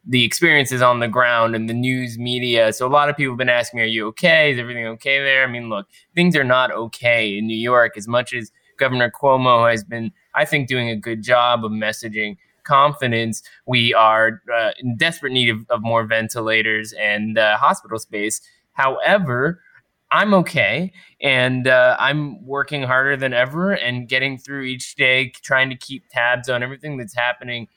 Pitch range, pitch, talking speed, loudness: 115-130 Hz, 125 Hz, 190 wpm, -18 LUFS